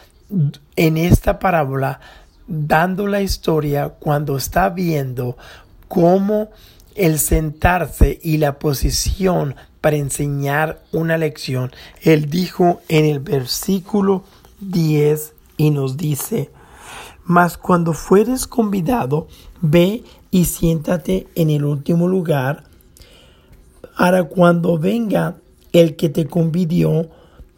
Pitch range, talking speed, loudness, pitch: 150-180 Hz, 100 wpm, -17 LUFS, 165 Hz